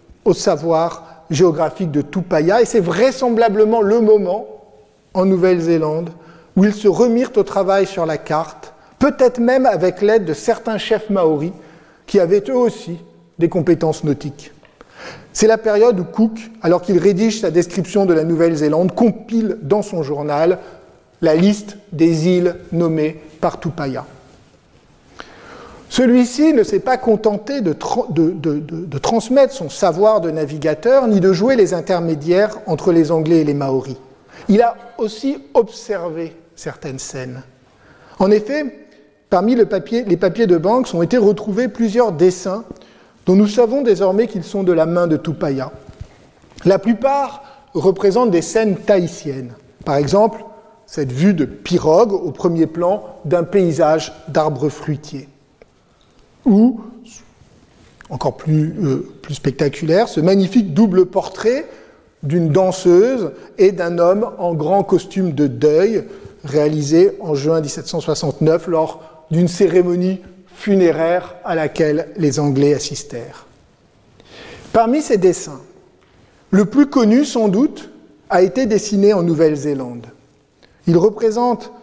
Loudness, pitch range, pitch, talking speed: -16 LUFS, 160-220 Hz, 180 Hz, 135 wpm